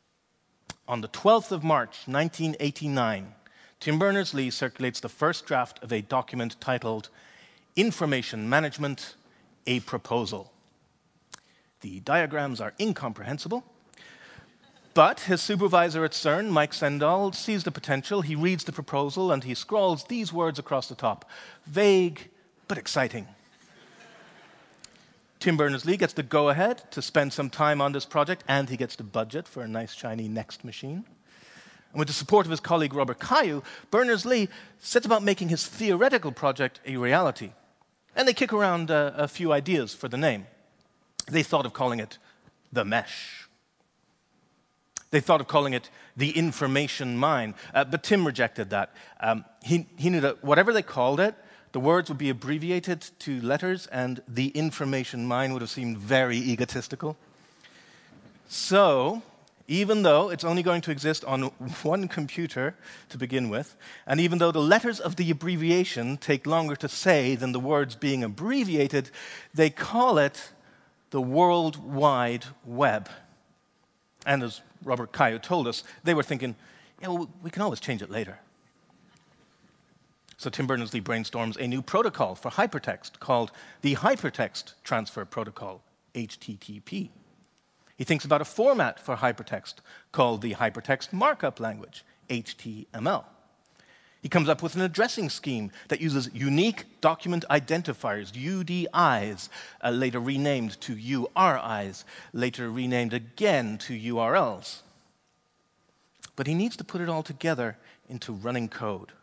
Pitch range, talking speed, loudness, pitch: 125-175 Hz, 145 wpm, -27 LUFS, 145 Hz